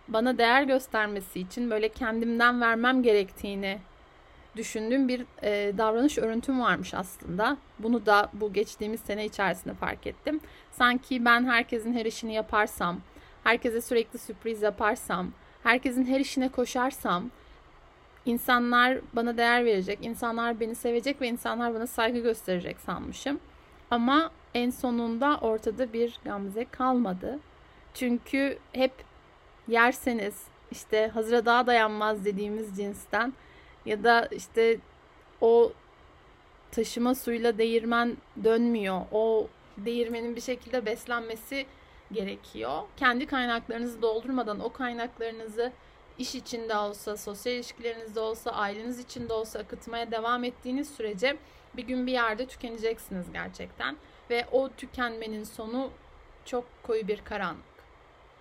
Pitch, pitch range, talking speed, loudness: 235 Hz, 220-250 Hz, 115 wpm, -28 LUFS